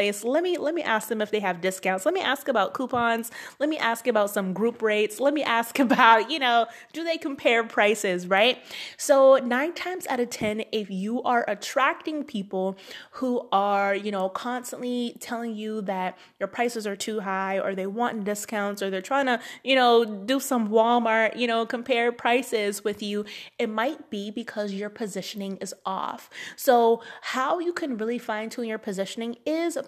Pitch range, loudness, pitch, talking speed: 205-255 Hz, -25 LUFS, 230 Hz, 190 wpm